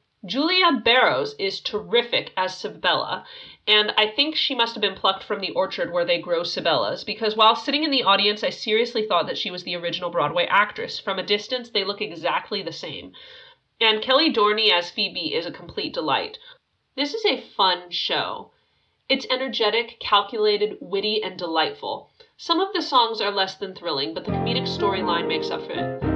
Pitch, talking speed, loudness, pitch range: 220 Hz, 185 wpm, -22 LUFS, 200-310 Hz